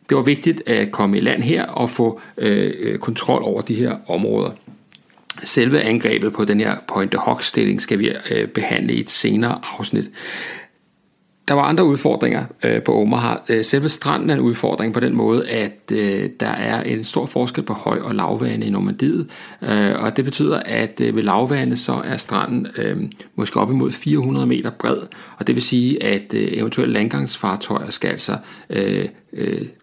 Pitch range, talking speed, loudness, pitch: 100-135 Hz, 180 wpm, -19 LUFS, 110 Hz